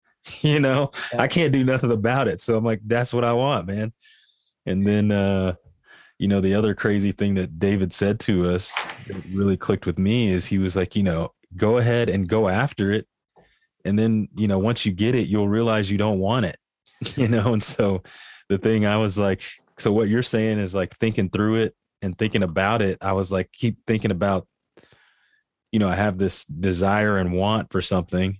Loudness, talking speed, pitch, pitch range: -22 LUFS, 210 wpm, 105 Hz, 95-115 Hz